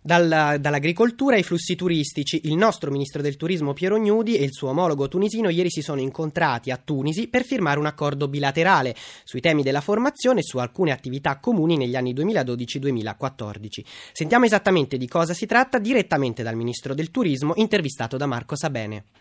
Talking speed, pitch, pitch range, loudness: 170 wpm, 155 Hz, 135-185 Hz, -22 LUFS